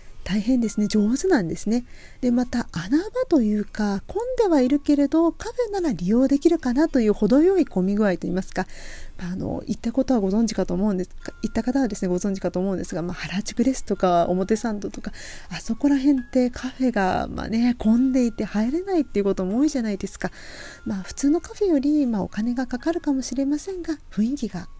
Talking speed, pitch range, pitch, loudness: 395 characters per minute, 200-285 Hz, 240 Hz, -23 LUFS